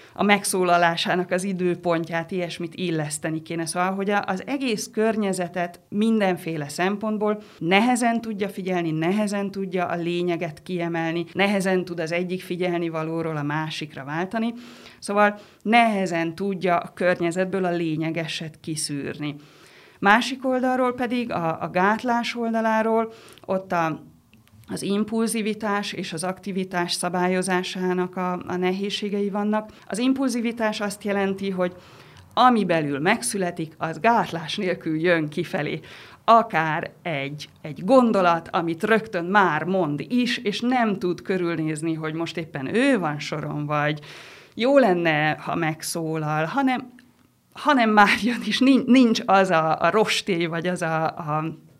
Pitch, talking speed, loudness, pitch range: 180 Hz, 125 wpm, -23 LUFS, 165-210 Hz